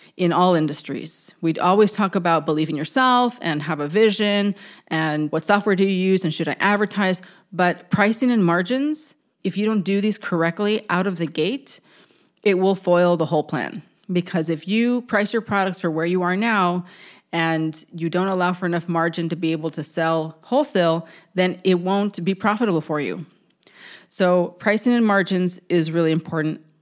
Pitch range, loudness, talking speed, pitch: 165-205 Hz, -21 LUFS, 180 wpm, 180 Hz